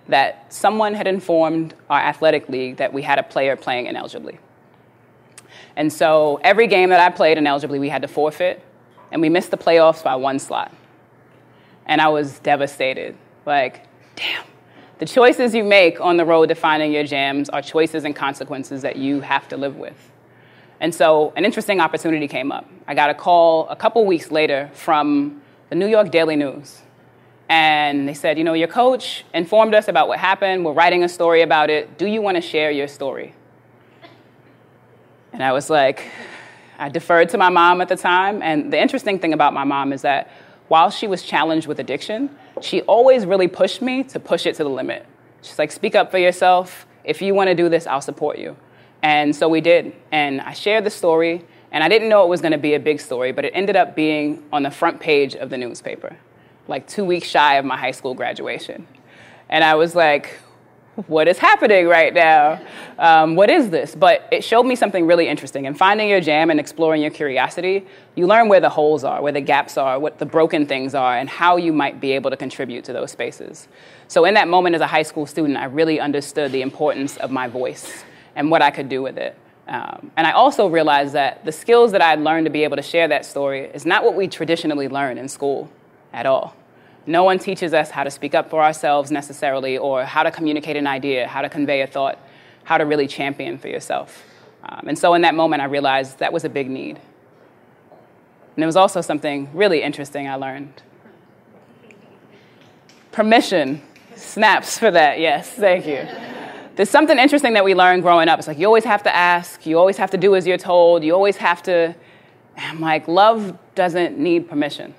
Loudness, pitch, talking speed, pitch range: -17 LUFS, 160 Hz, 210 wpm, 145-185 Hz